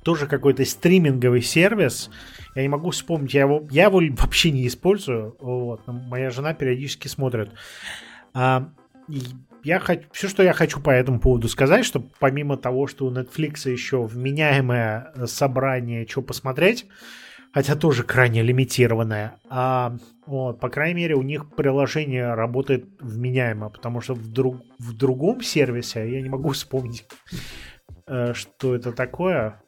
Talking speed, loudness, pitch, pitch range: 145 wpm, -22 LUFS, 130 Hz, 125-150 Hz